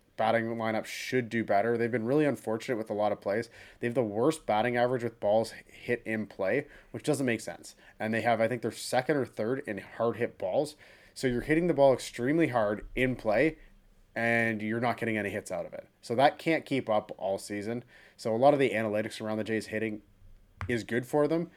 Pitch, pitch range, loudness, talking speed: 115 Hz, 105-125 Hz, -30 LUFS, 225 wpm